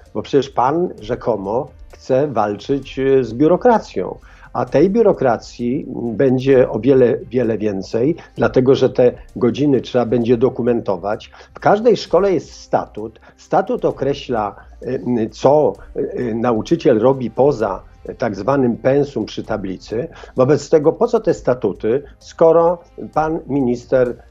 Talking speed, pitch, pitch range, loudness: 120 wpm, 130 Hz, 120-140 Hz, -17 LUFS